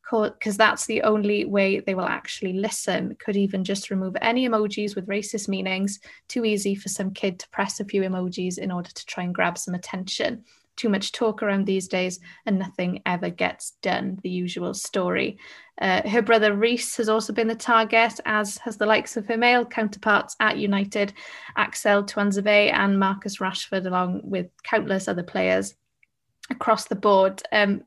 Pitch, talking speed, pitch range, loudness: 205 Hz, 180 wpm, 190-220 Hz, -24 LUFS